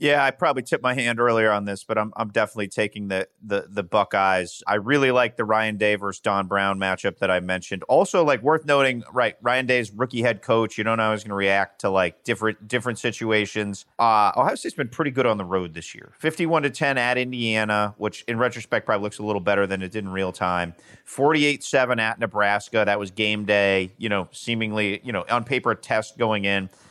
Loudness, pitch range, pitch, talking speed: -23 LUFS, 100-120 Hz, 105 Hz, 230 wpm